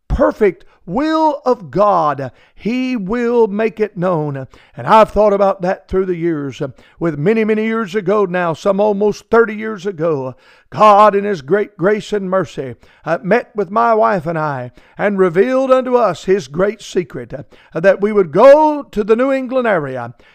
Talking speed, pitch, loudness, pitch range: 170 wpm, 200 Hz, -15 LUFS, 170-220 Hz